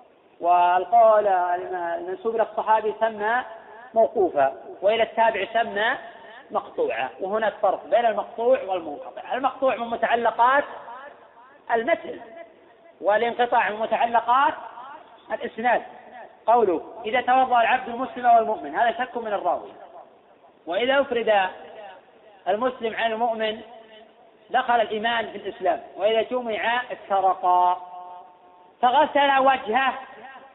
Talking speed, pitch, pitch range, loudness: 90 wpm, 230 Hz, 215-255 Hz, -23 LUFS